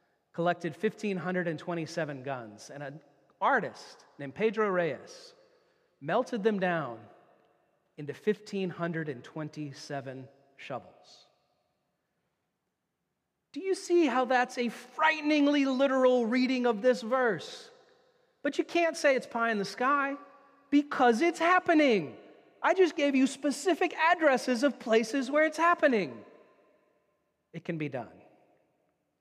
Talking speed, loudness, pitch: 110 wpm, -29 LUFS, 245 Hz